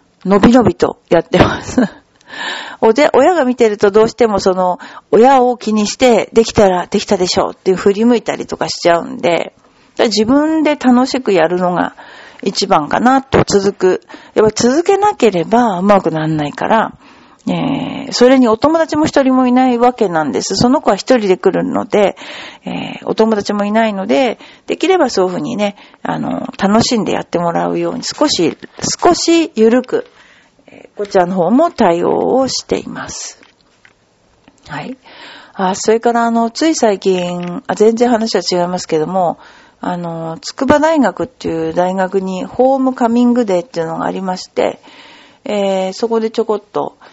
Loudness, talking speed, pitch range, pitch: -13 LUFS, 325 characters per minute, 190-255 Hz, 220 Hz